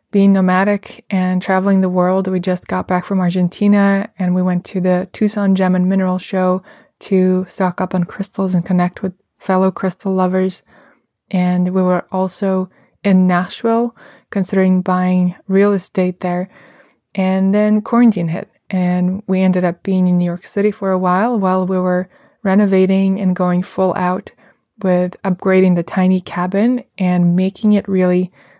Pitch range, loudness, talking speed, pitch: 180-195 Hz, -16 LUFS, 160 wpm, 185 Hz